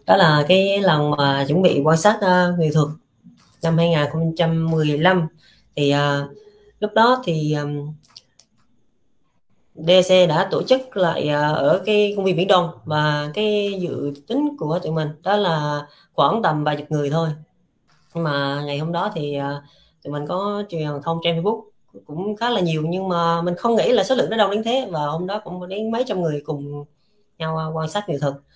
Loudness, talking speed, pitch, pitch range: -20 LUFS, 190 wpm, 165 Hz, 150-195 Hz